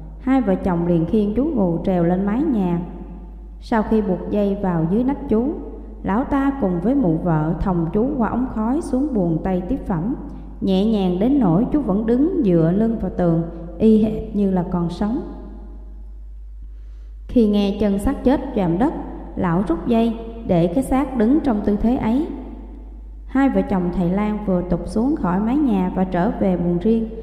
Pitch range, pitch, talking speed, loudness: 180-245 Hz, 205 Hz, 190 wpm, -20 LUFS